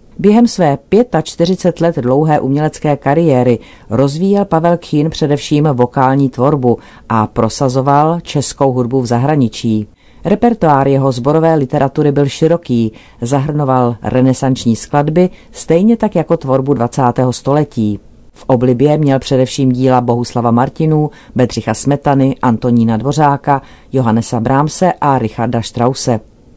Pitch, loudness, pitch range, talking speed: 135 Hz, -13 LUFS, 120-150 Hz, 115 wpm